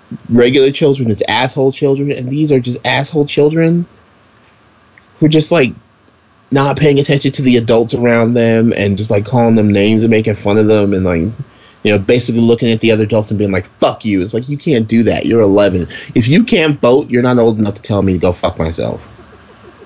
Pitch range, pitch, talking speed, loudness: 105-135 Hz, 115 Hz, 220 wpm, -12 LUFS